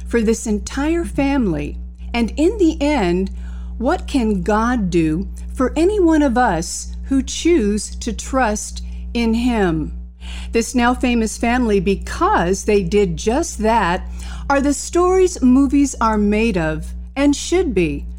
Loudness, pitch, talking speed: -18 LUFS, 220 Hz, 140 wpm